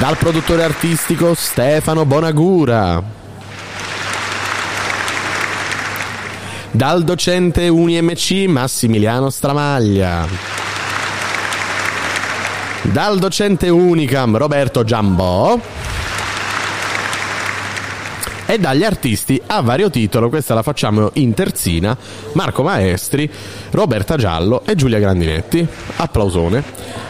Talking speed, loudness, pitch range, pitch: 75 wpm, -16 LUFS, 100-160 Hz, 120 Hz